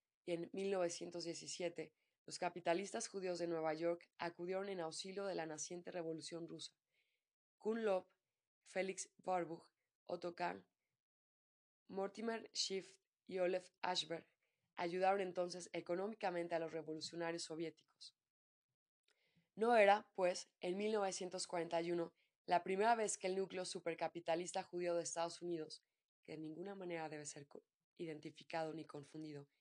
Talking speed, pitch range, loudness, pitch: 120 wpm, 160-185 Hz, -43 LUFS, 175 Hz